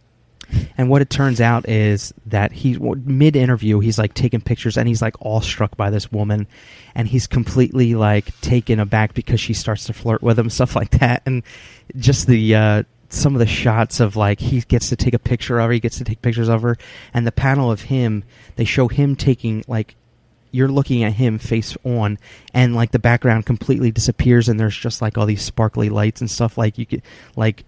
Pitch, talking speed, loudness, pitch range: 115 Hz, 210 wpm, -18 LUFS, 110-125 Hz